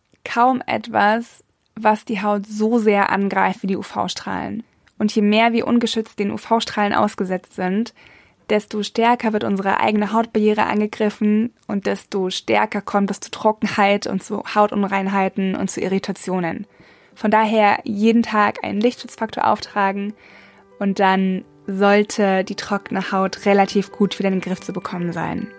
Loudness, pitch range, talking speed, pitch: -19 LUFS, 195-220 Hz, 145 wpm, 205 Hz